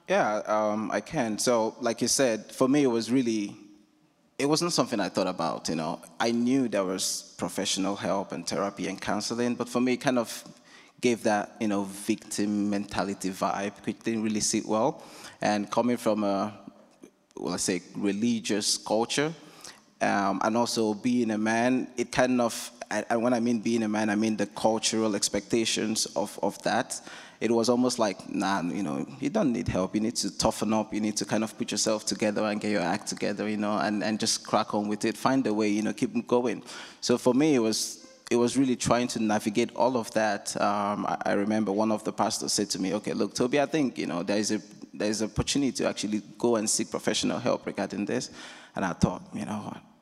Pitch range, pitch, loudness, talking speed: 105-120 Hz, 110 Hz, -28 LUFS, 215 wpm